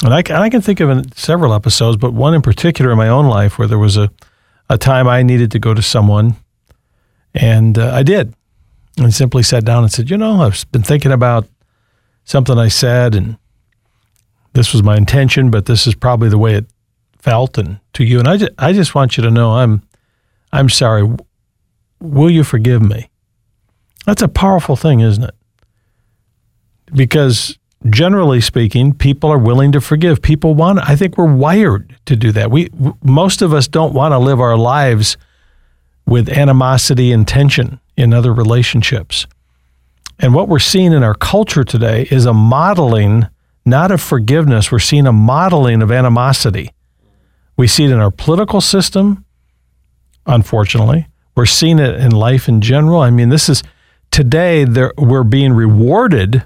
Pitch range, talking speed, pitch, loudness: 110-140 Hz, 175 wpm, 120 Hz, -11 LUFS